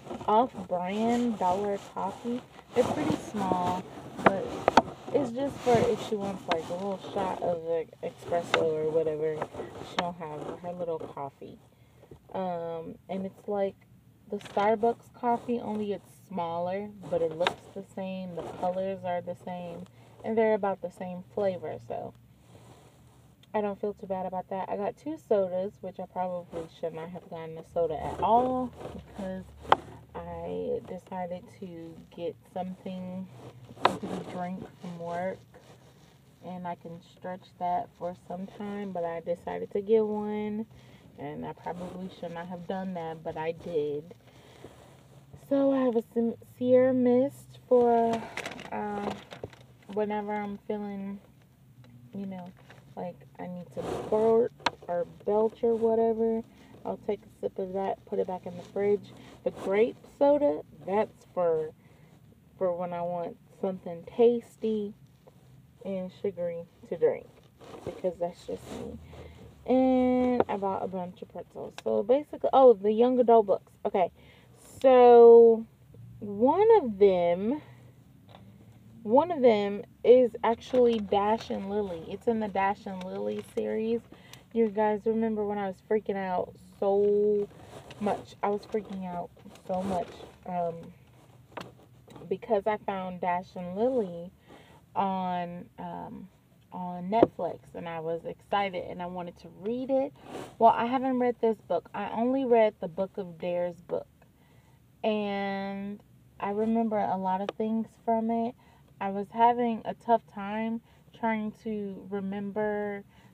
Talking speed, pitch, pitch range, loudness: 140 wpm, 195 Hz, 175-225 Hz, -29 LUFS